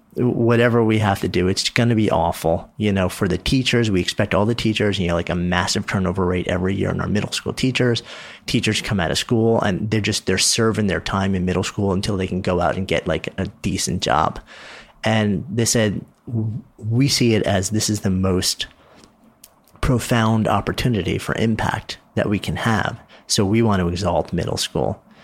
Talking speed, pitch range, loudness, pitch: 205 wpm, 95-115 Hz, -20 LUFS, 105 Hz